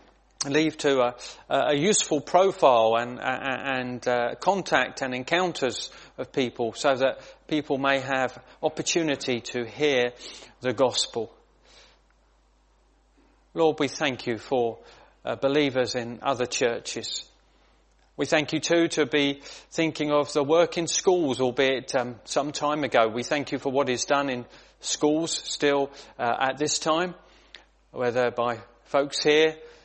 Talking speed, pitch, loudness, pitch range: 145 wpm, 140 Hz, -25 LUFS, 125-155 Hz